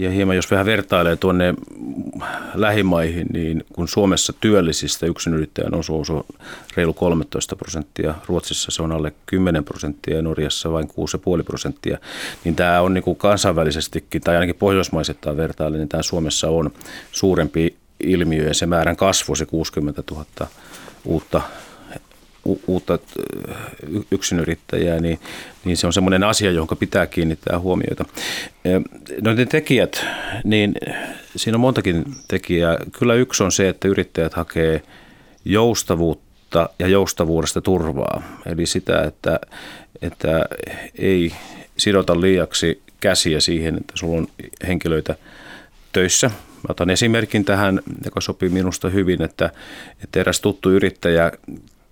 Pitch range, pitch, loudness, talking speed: 80-95 Hz, 85 Hz, -20 LUFS, 130 wpm